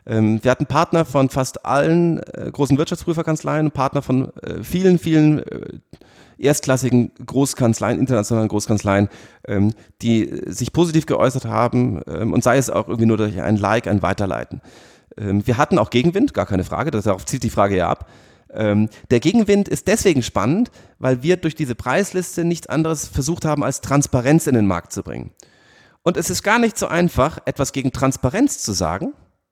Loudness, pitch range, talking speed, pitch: -19 LUFS, 110-155 Hz, 160 wpm, 130 Hz